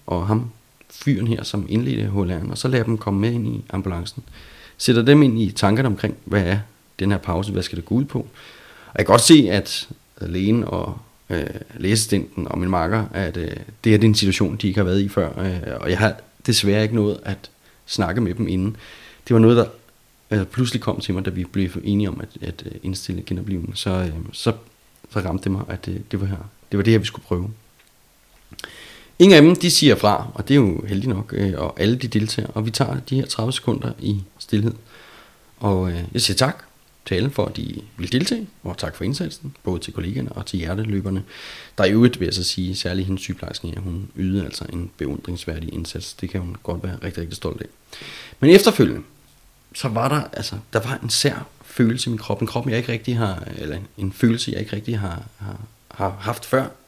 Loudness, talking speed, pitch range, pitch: -21 LUFS, 220 wpm, 95-115 Hz, 105 Hz